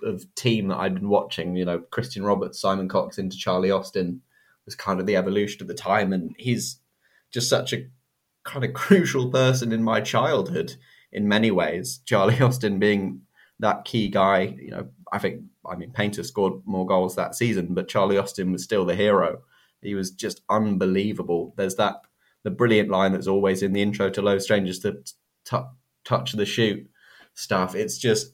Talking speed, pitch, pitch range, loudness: 185 wpm, 100 Hz, 95-110 Hz, -24 LUFS